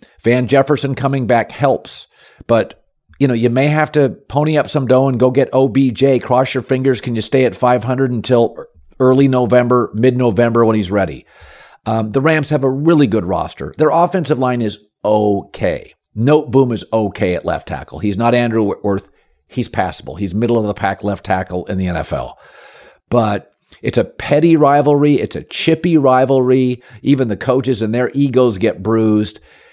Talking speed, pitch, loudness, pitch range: 180 wpm, 125 Hz, -15 LUFS, 110-135 Hz